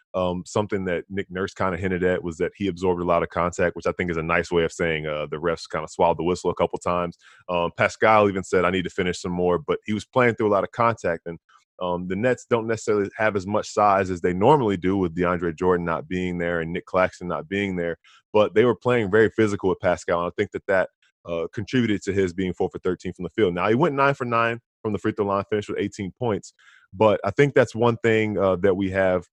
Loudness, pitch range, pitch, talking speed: -23 LUFS, 90-105 Hz, 95 Hz, 270 wpm